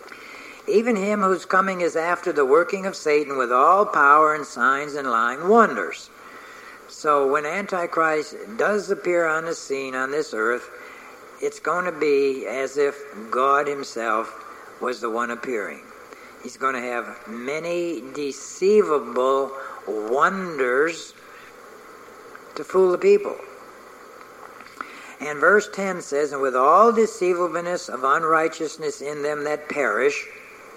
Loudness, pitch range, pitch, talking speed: -21 LUFS, 140-210 Hz, 165 Hz, 130 wpm